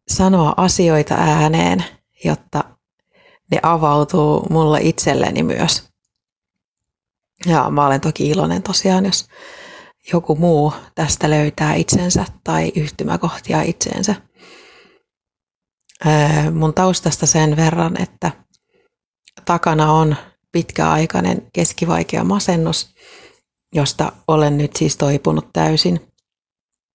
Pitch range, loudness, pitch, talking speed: 150-185 Hz, -16 LUFS, 160 Hz, 90 wpm